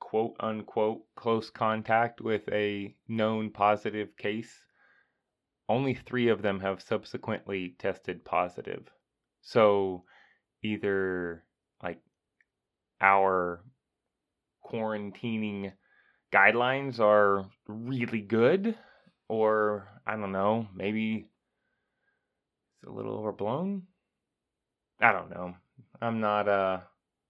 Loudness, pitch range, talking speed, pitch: -29 LUFS, 100-115 Hz, 90 wpm, 105 Hz